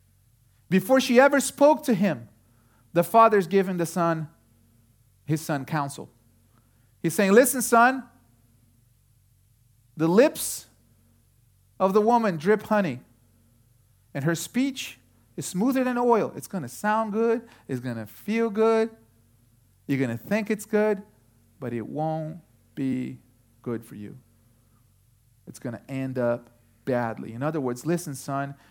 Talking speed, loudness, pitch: 140 wpm, -24 LUFS, 130 Hz